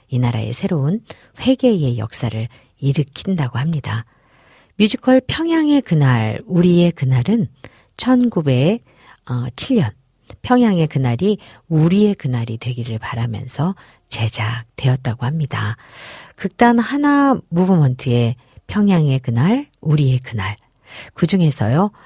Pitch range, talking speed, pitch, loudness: 120-195 Hz, 240 characters per minute, 140 Hz, -17 LUFS